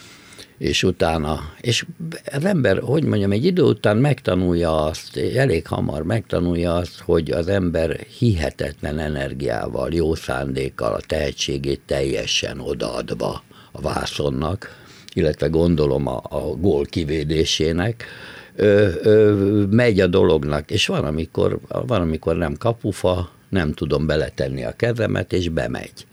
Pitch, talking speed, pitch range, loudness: 85 Hz, 125 wpm, 75-105 Hz, -20 LUFS